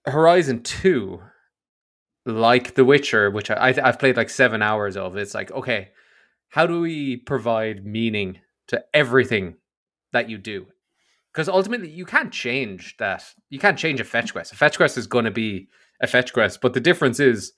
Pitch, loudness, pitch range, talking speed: 125 Hz, -21 LUFS, 110-150 Hz, 180 wpm